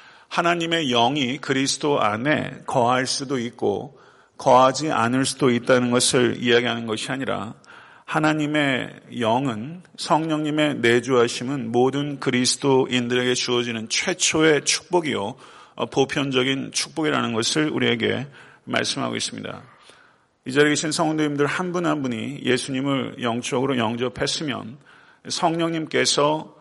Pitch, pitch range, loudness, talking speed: 135 Hz, 125-155 Hz, -21 LUFS, 300 characters per minute